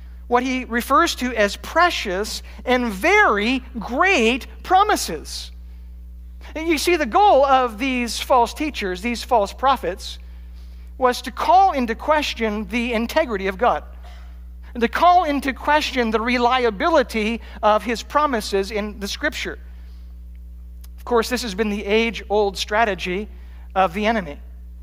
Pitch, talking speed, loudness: 225 Hz, 135 wpm, -19 LUFS